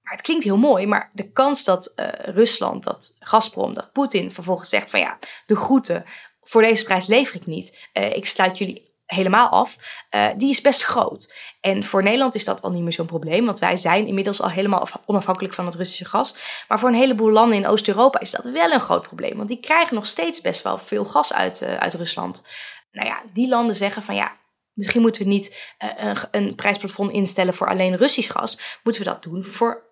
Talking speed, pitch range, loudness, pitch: 220 wpm, 185-235 Hz, -20 LUFS, 205 Hz